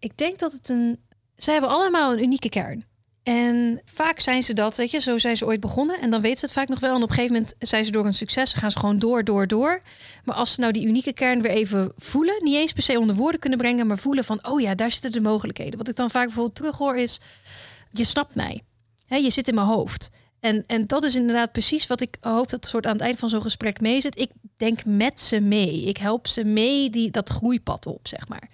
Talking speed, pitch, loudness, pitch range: 265 wpm, 235 Hz, -22 LUFS, 215-260 Hz